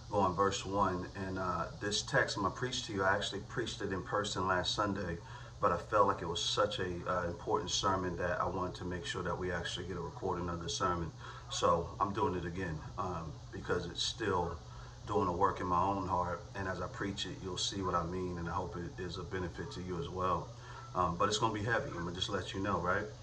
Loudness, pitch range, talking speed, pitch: -36 LUFS, 90-100 Hz, 255 wpm, 95 Hz